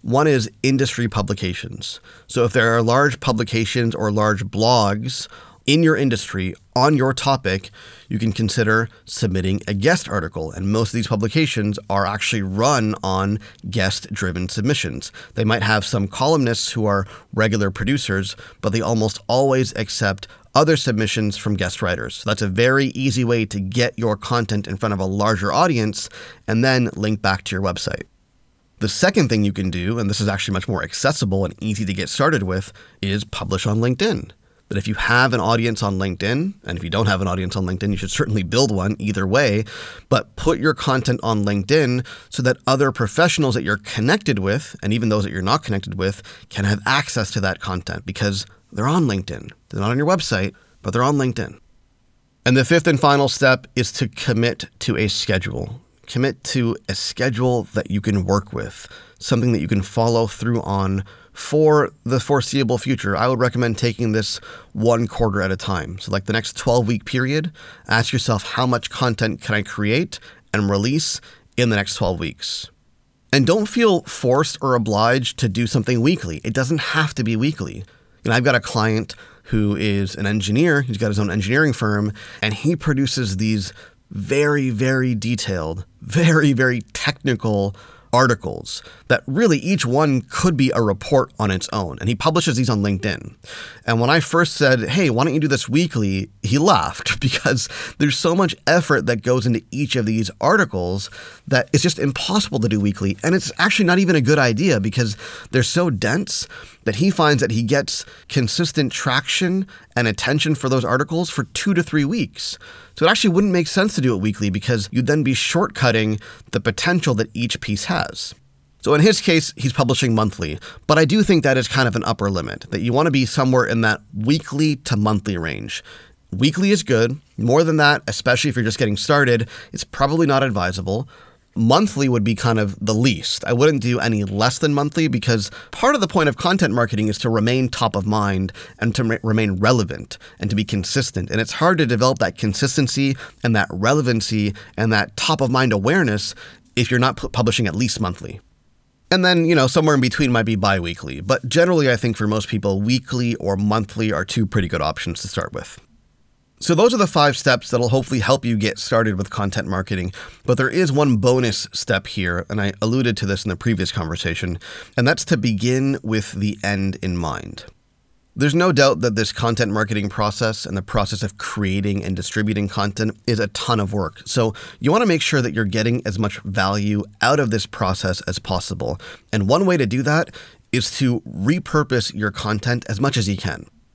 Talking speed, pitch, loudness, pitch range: 200 wpm, 115 Hz, -19 LUFS, 100-135 Hz